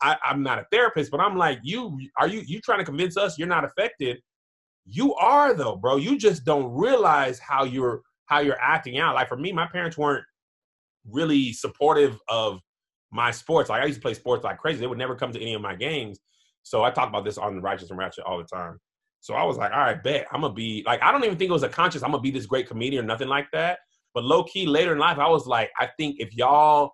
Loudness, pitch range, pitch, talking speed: -24 LUFS, 120-165 Hz, 140 Hz, 255 wpm